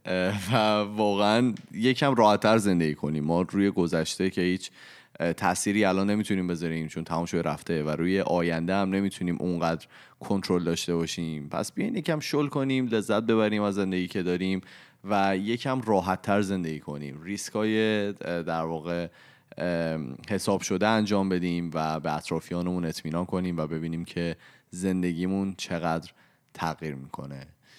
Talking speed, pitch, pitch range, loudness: 140 wpm, 90 Hz, 85-105 Hz, -27 LUFS